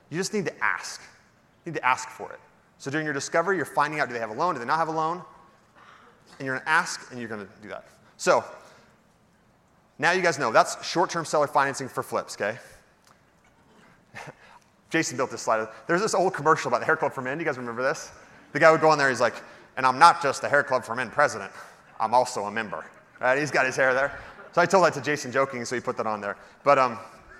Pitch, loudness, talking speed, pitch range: 140 Hz, -24 LUFS, 250 wpm, 120-160 Hz